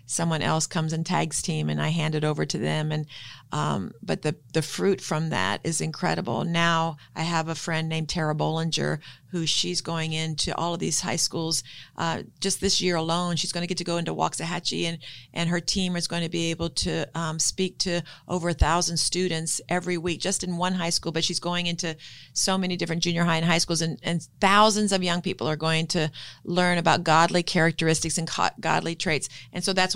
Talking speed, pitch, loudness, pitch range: 215 wpm, 165 Hz, -25 LUFS, 160-175 Hz